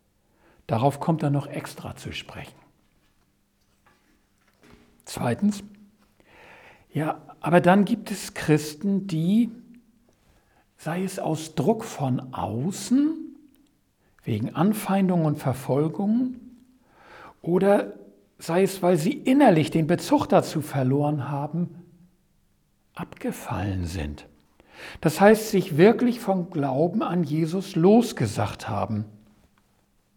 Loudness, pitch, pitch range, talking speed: -24 LUFS, 175 Hz, 140-205 Hz, 95 wpm